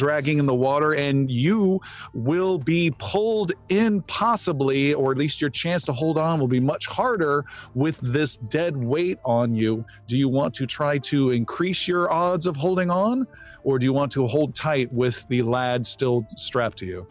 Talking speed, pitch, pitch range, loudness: 195 wpm, 145 Hz, 125-175 Hz, -23 LUFS